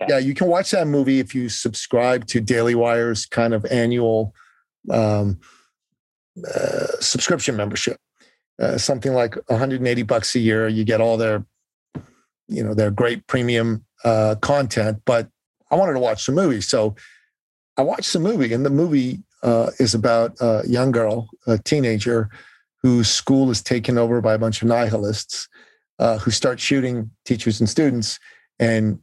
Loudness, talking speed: -20 LUFS, 160 wpm